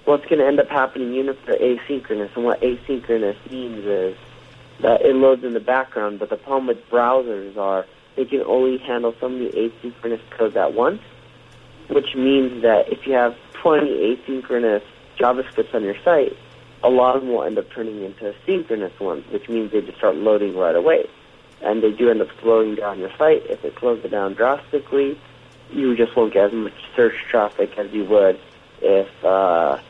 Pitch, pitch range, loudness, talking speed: 125 Hz, 115-140 Hz, -20 LUFS, 195 wpm